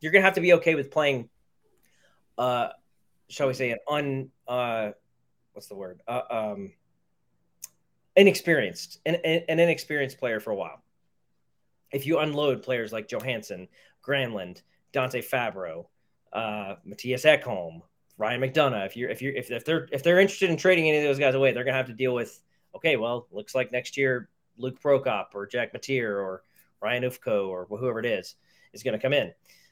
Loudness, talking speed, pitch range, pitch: -26 LUFS, 175 wpm, 110-150 Hz, 130 Hz